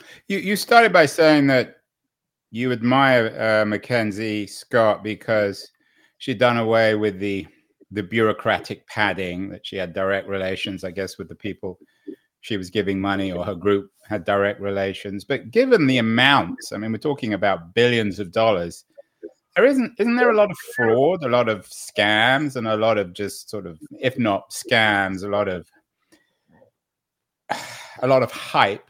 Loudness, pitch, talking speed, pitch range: -20 LUFS, 110 Hz, 170 wpm, 100-125 Hz